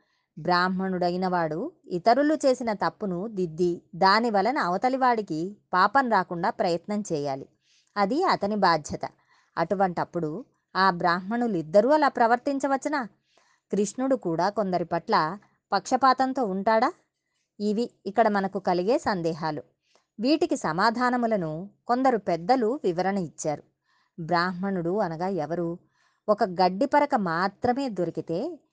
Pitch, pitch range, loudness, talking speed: 195 Hz, 175-240 Hz, -25 LUFS, 95 wpm